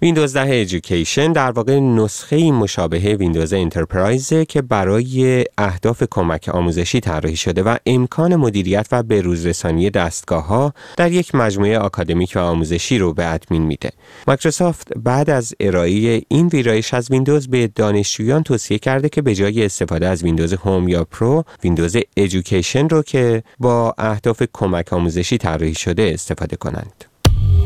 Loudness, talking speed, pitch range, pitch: -17 LUFS, 145 wpm, 90-130 Hz, 110 Hz